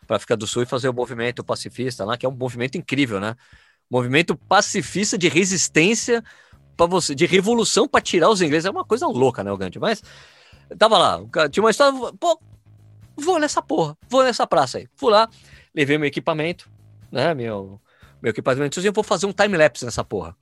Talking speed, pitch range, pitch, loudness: 205 wpm, 120-200 Hz, 155 Hz, -20 LUFS